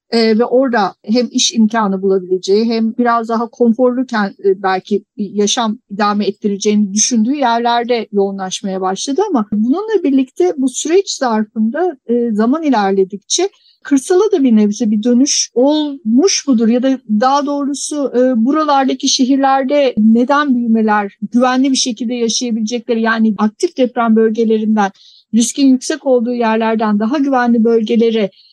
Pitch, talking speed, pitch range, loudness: 235 Hz, 130 wpm, 220-270 Hz, -14 LUFS